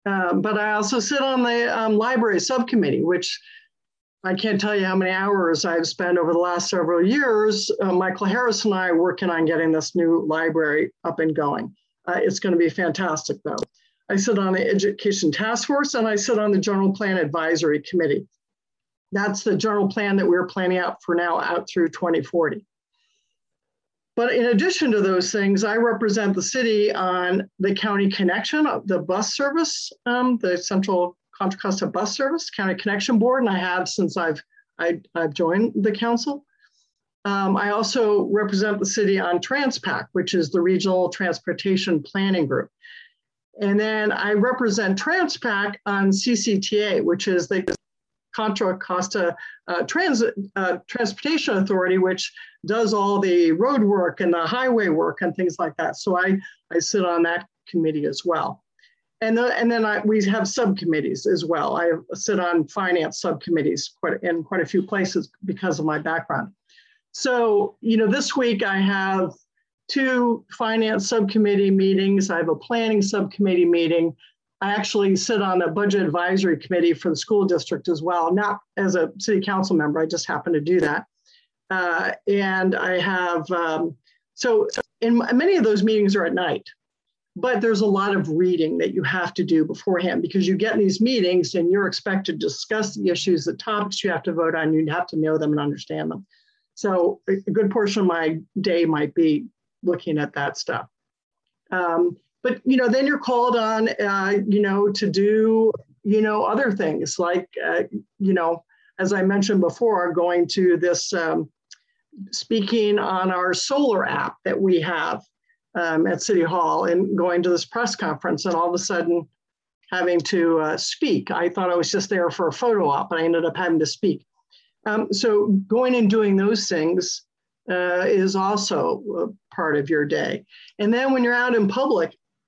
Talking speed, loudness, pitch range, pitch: 180 wpm, -22 LUFS, 175-220 Hz, 195 Hz